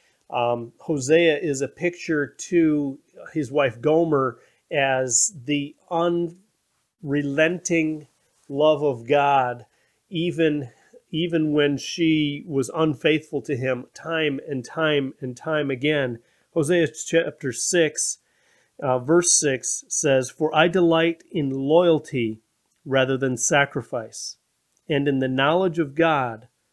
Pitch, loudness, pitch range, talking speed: 150 Hz, -22 LUFS, 135-165 Hz, 110 wpm